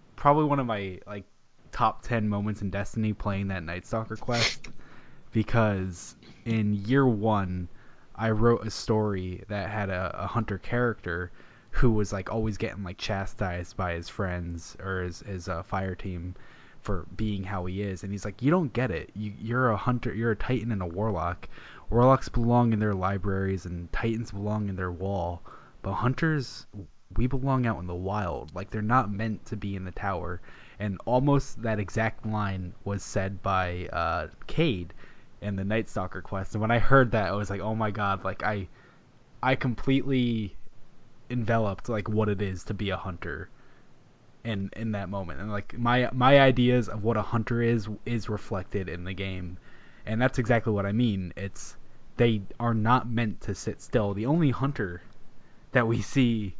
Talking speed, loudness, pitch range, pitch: 185 wpm, -28 LUFS, 95-115 Hz, 105 Hz